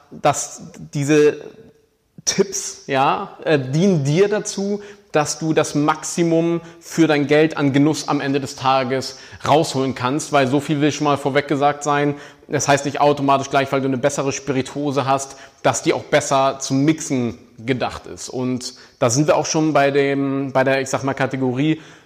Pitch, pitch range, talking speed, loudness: 145 Hz, 135-155 Hz, 175 wpm, -19 LUFS